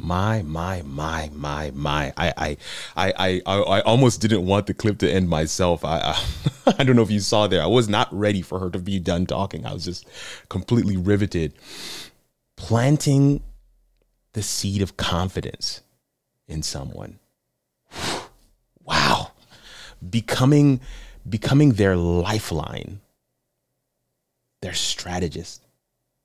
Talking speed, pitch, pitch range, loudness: 130 wpm, 100 Hz, 85-115 Hz, -22 LUFS